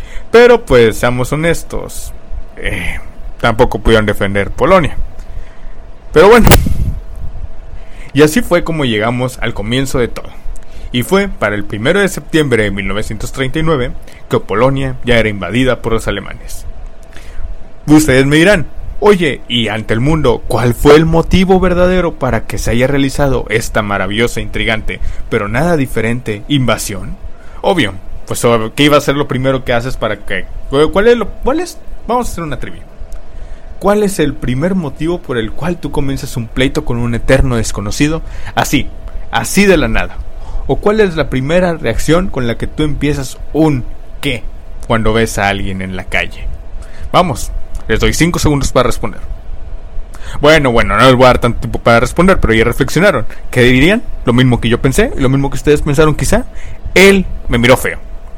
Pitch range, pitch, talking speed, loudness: 100-150 Hz, 120 Hz, 170 wpm, -12 LUFS